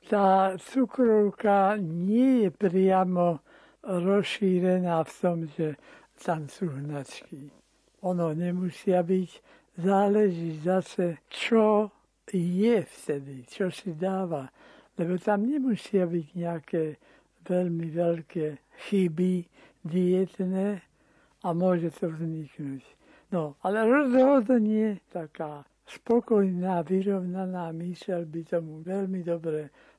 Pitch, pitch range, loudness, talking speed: 180 Hz, 170-200 Hz, -27 LUFS, 95 wpm